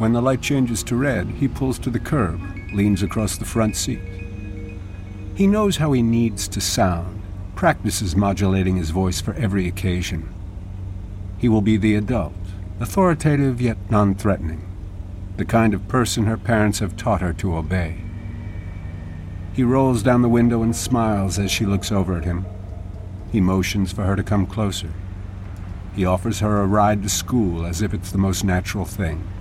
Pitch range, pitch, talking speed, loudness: 95-110 Hz, 100 Hz, 170 wpm, -20 LUFS